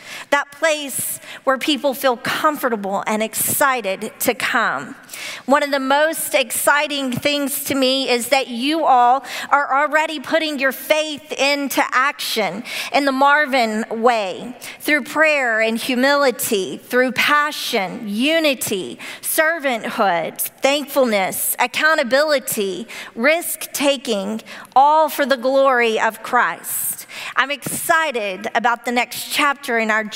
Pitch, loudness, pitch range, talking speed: 275 Hz, -18 LUFS, 245-295 Hz, 115 wpm